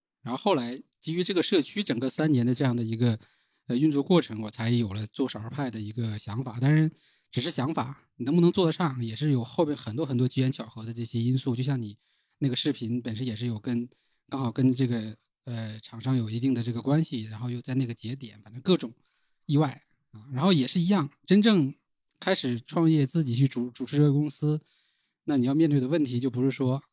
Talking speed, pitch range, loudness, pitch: 325 characters per minute, 120-150 Hz, -27 LUFS, 130 Hz